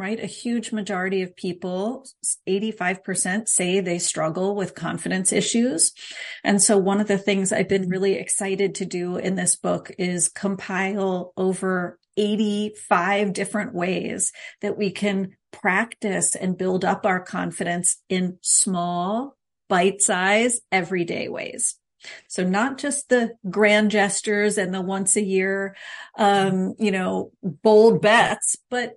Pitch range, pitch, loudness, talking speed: 185-210 Hz, 195 Hz, -22 LUFS, 135 wpm